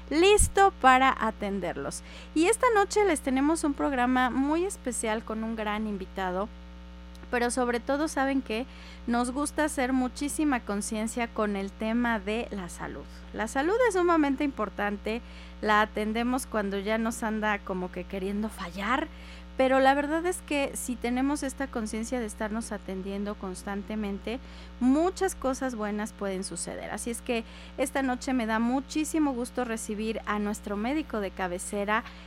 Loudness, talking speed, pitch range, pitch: -28 LUFS, 150 wpm, 205-270 Hz, 225 Hz